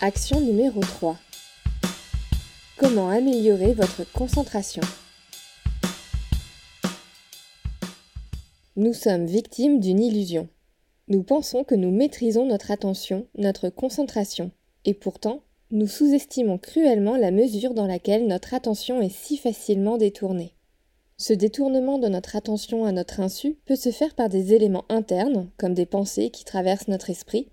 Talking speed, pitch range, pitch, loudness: 125 wpm, 195-245 Hz, 215 Hz, -24 LUFS